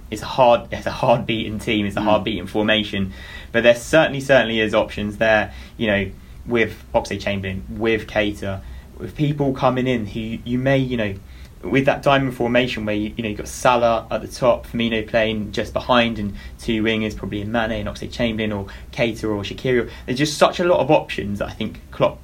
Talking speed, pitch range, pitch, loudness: 205 wpm, 100-120 Hz, 110 Hz, -20 LUFS